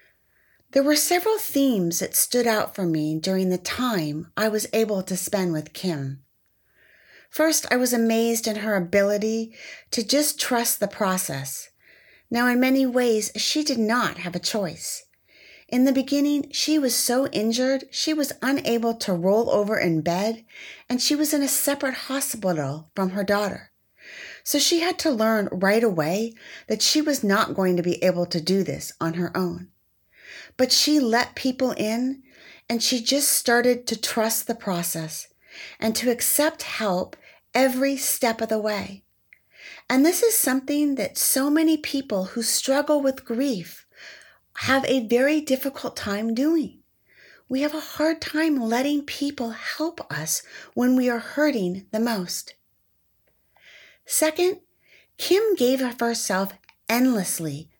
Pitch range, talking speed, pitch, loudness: 200-280 Hz, 155 wpm, 240 Hz, -23 LUFS